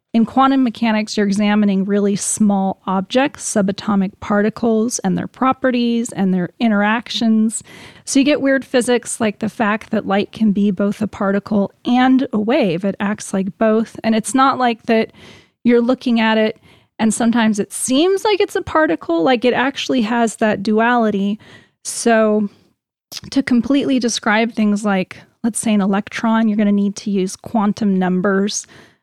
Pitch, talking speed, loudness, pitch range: 220 Hz, 165 wpm, -17 LUFS, 205-245 Hz